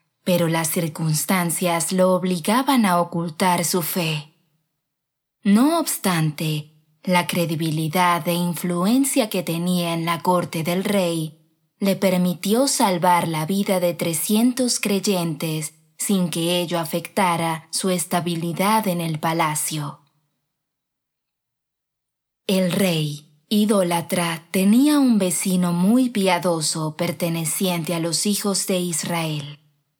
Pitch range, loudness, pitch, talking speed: 160-190 Hz, -21 LUFS, 175 Hz, 105 wpm